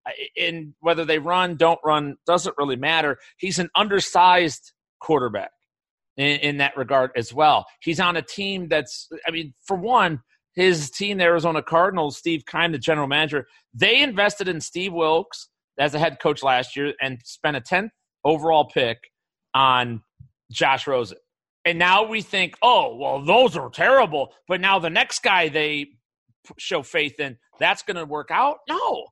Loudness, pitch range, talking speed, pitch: -21 LUFS, 145-180 Hz, 170 wpm, 160 Hz